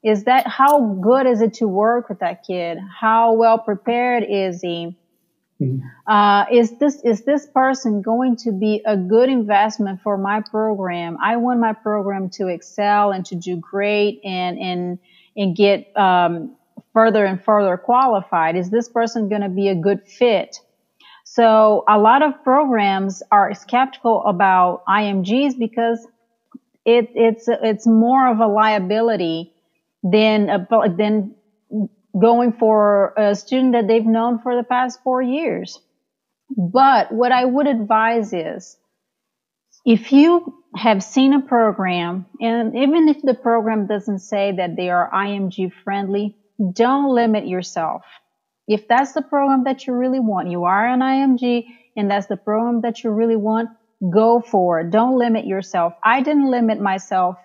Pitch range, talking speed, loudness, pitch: 195-240 Hz, 155 wpm, -17 LUFS, 220 Hz